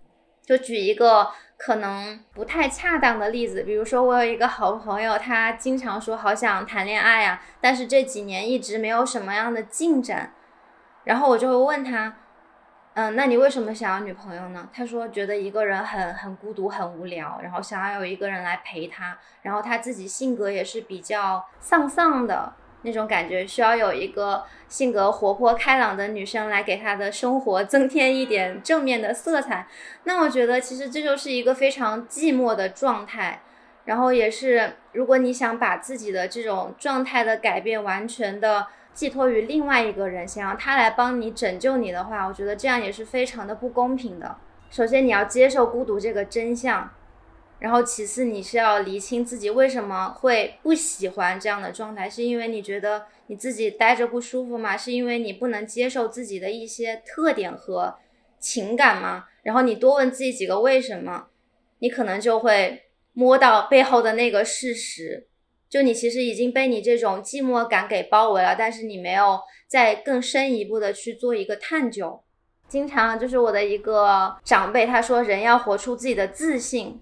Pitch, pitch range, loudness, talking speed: 230 Hz, 205-255 Hz, -22 LUFS, 280 characters per minute